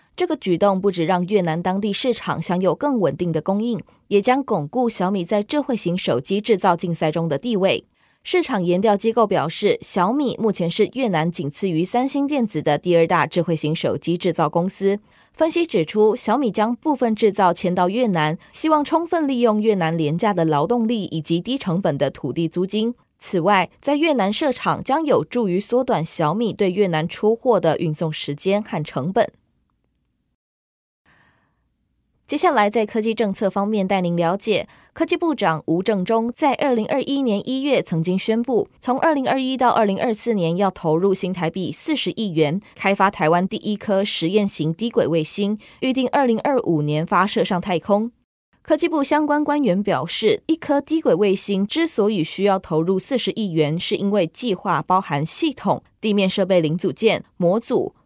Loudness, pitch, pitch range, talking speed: -20 LUFS, 200 Hz, 175-240 Hz, 275 characters per minute